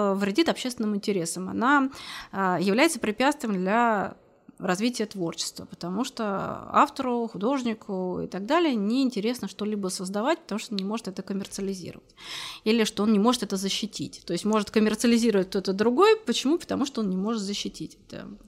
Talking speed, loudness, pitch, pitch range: 155 wpm, -26 LUFS, 215 Hz, 195-240 Hz